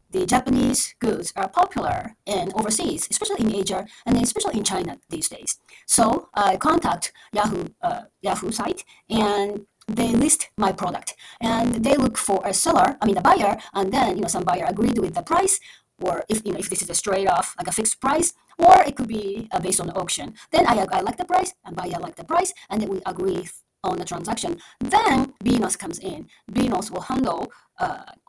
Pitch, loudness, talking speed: 240 Hz, -22 LUFS, 210 wpm